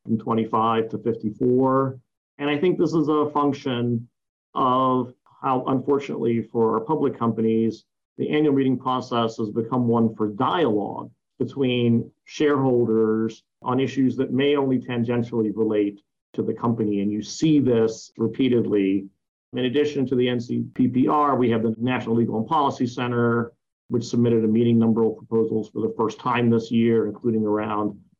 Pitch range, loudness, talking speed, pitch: 110-130 Hz, -23 LUFS, 155 wpm, 120 Hz